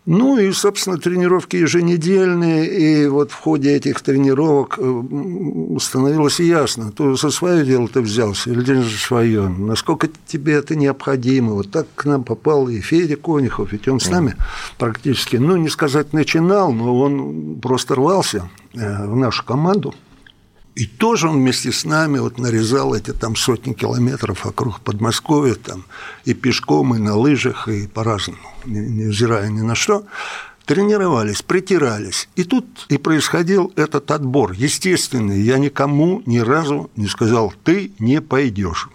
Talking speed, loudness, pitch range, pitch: 145 wpm, -17 LUFS, 115-160 Hz, 135 Hz